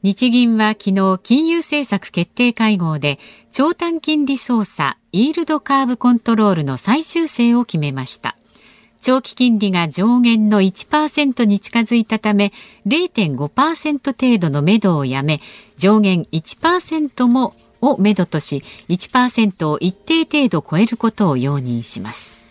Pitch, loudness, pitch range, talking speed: 220 Hz, -16 LUFS, 180-260 Hz, 240 characters per minute